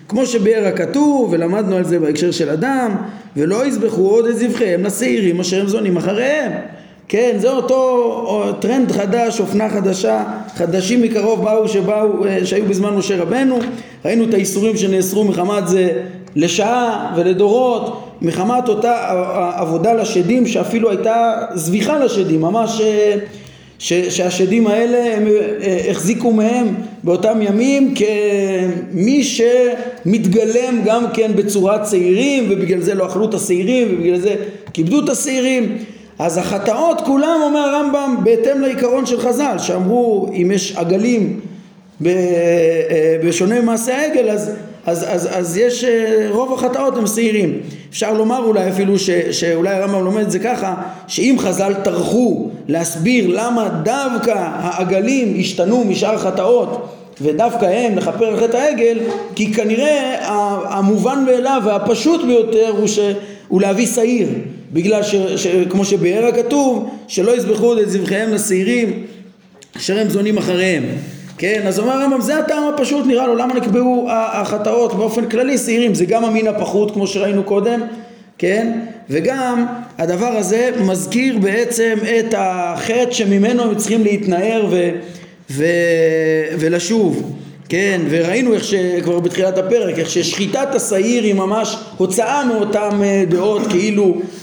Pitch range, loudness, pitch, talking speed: 185-235 Hz, -15 LUFS, 210 Hz, 130 wpm